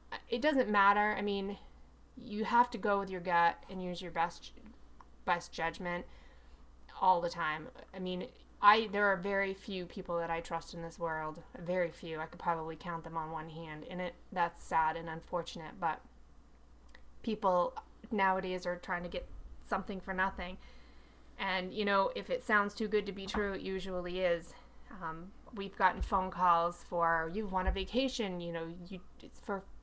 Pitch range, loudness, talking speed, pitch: 165-200 Hz, -35 LUFS, 180 wpm, 180 Hz